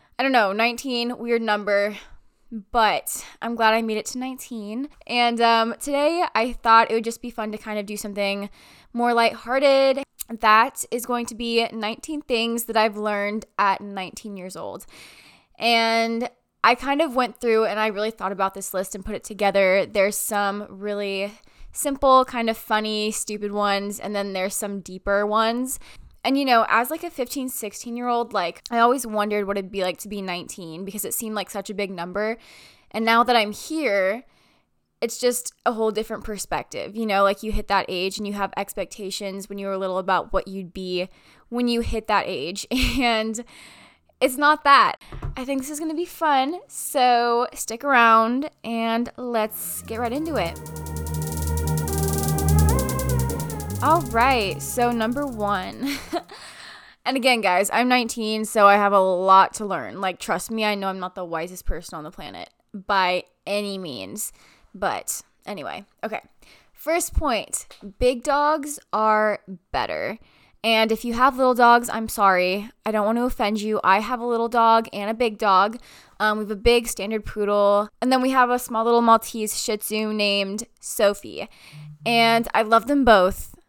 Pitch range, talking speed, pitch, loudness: 200-240 Hz, 180 wpm, 220 Hz, -22 LUFS